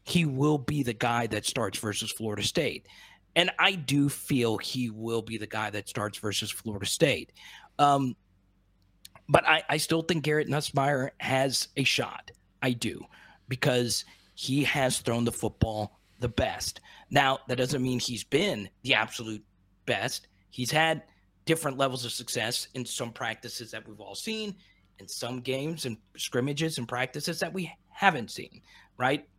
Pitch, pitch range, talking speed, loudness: 120 Hz, 105-140 Hz, 160 wpm, -29 LUFS